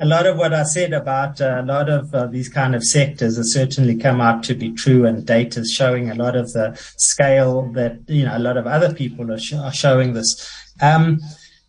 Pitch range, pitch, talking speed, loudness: 120-145 Hz, 130 Hz, 230 wpm, -18 LUFS